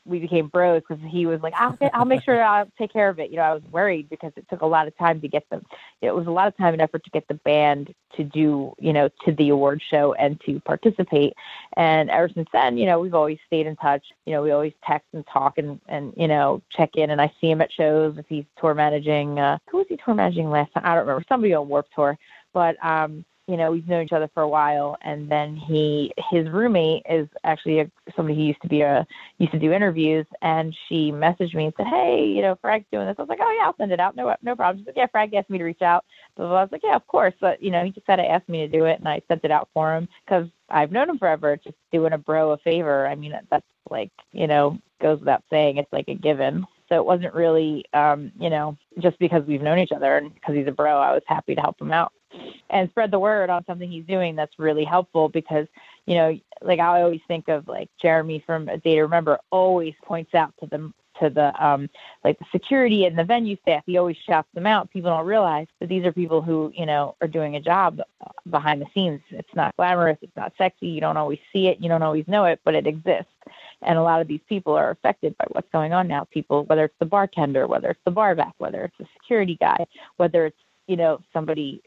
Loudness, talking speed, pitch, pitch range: -22 LUFS, 260 wpm, 160 Hz, 150-180 Hz